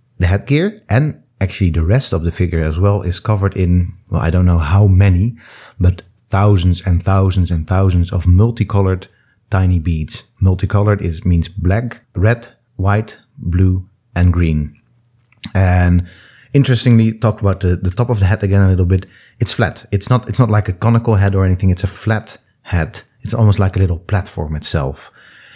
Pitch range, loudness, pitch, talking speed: 90-115 Hz, -15 LUFS, 95 Hz, 180 wpm